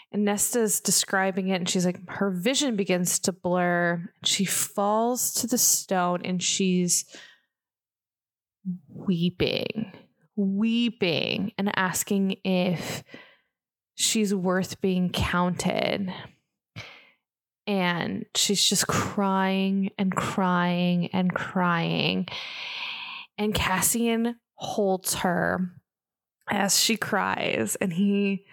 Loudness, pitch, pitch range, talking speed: -25 LUFS, 190 Hz, 180-205 Hz, 95 wpm